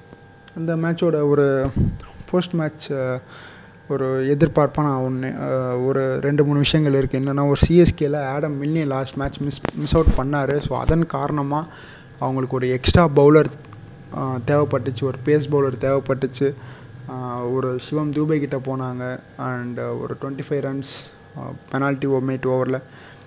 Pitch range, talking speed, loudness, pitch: 130-145 Hz, 130 wpm, -21 LUFS, 135 Hz